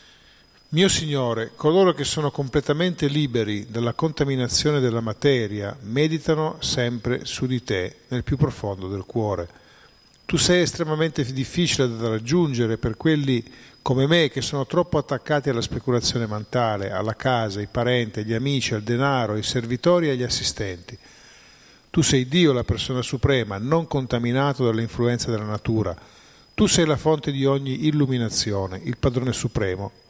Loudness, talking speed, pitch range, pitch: -23 LUFS, 145 wpm, 115-145 Hz, 125 Hz